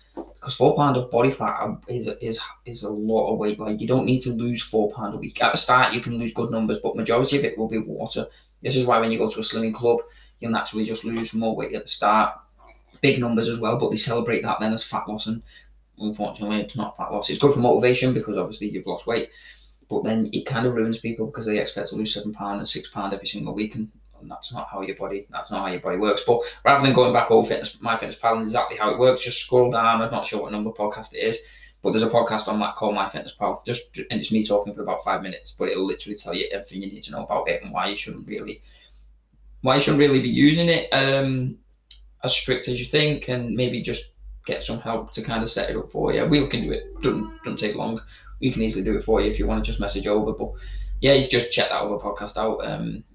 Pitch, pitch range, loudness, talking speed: 115 Hz, 105-125 Hz, -23 LUFS, 270 wpm